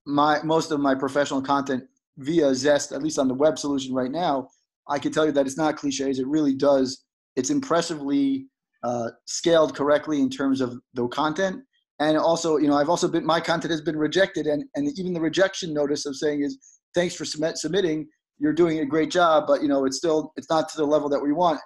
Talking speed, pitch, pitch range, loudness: 220 wpm, 150 Hz, 140-165 Hz, -24 LUFS